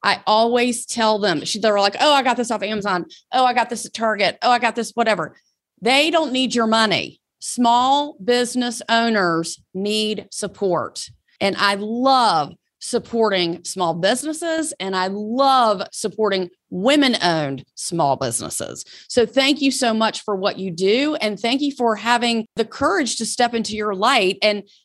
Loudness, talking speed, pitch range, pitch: -19 LUFS, 165 wpm, 200-245 Hz, 220 Hz